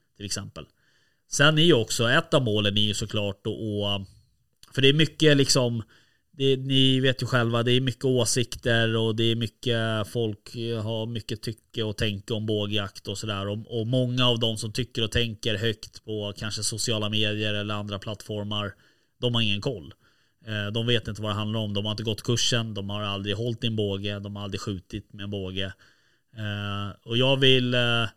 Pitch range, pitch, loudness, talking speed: 105-120 Hz, 110 Hz, -25 LUFS, 200 wpm